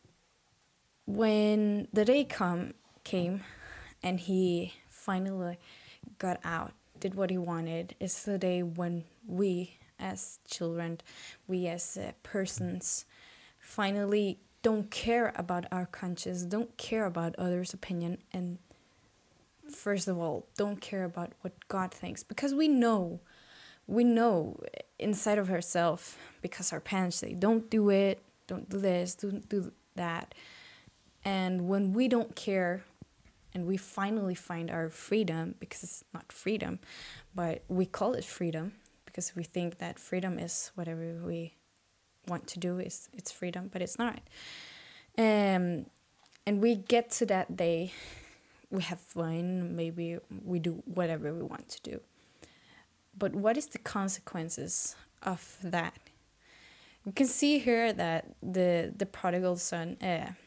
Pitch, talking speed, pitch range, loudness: 185 Hz, 140 wpm, 175-205 Hz, -33 LUFS